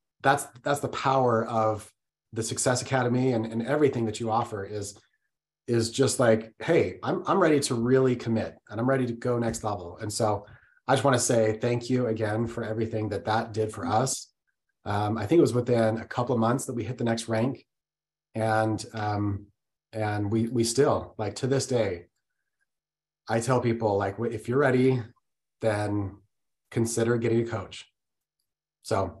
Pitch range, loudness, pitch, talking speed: 110-130 Hz, -27 LUFS, 115 Hz, 180 wpm